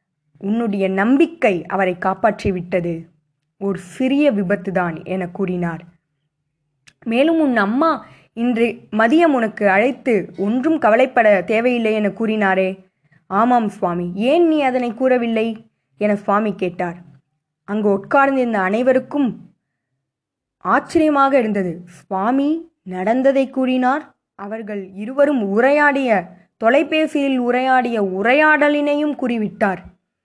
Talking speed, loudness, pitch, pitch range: 90 wpm, -17 LUFS, 215 Hz, 185-260 Hz